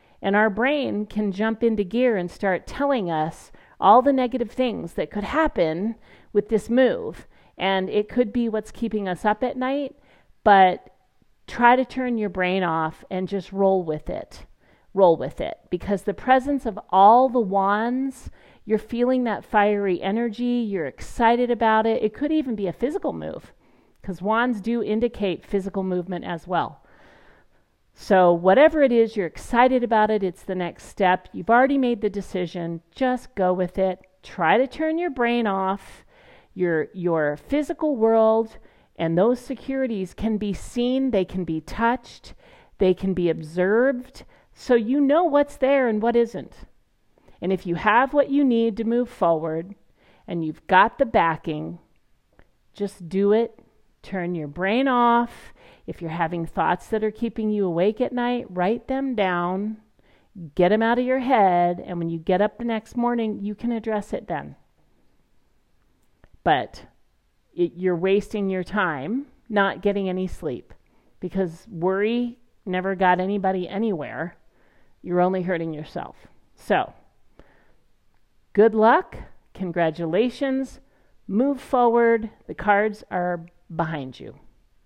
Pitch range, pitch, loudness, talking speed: 185-240 Hz, 210 Hz, -22 LUFS, 155 wpm